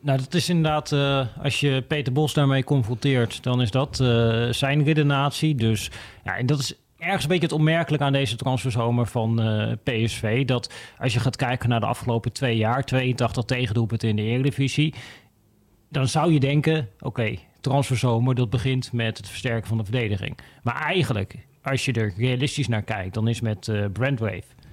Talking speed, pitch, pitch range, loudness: 185 wpm, 125 Hz, 115-140 Hz, -23 LUFS